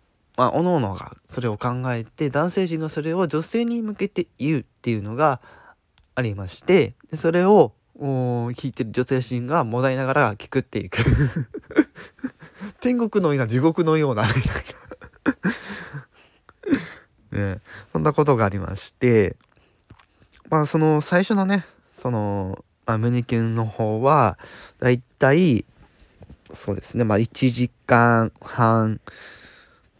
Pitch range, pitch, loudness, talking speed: 115-155 Hz, 125 Hz, -22 LUFS, 230 characters per minute